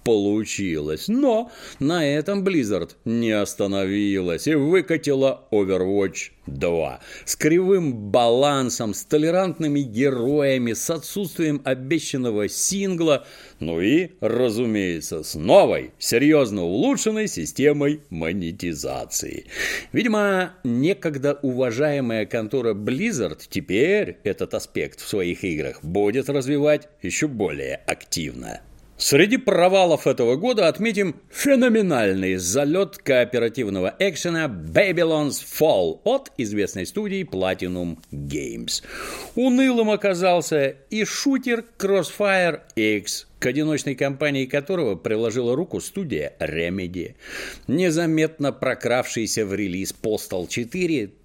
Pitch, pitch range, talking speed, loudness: 145 Hz, 115-180 Hz, 95 wpm, -22 LUFS